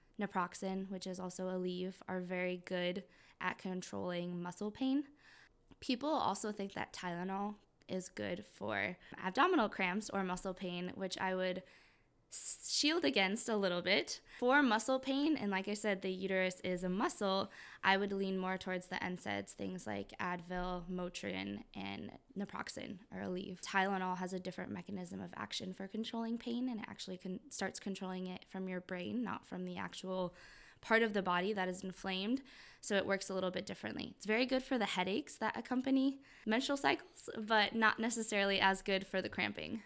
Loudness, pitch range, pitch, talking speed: -38 LUFS, 185-220 Hz, 190 Hz, 175 wpm